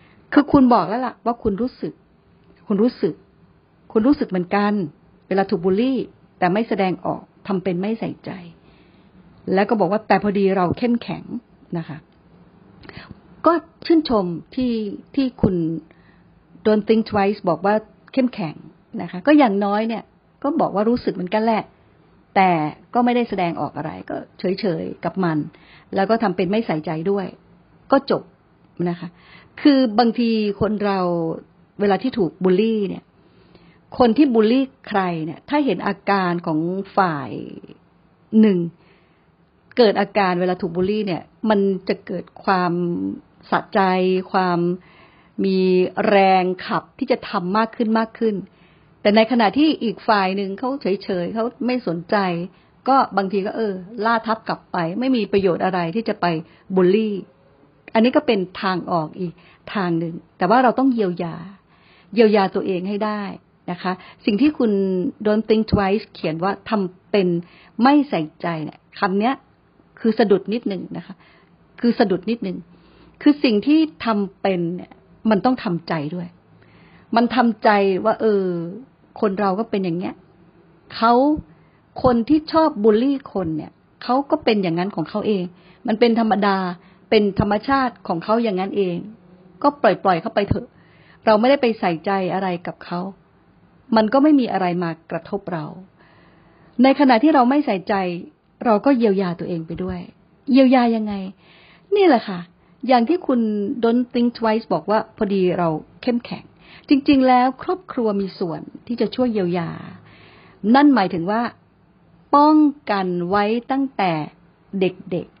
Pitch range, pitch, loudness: 180-230 Hz, 200 Hz, -20 LUFS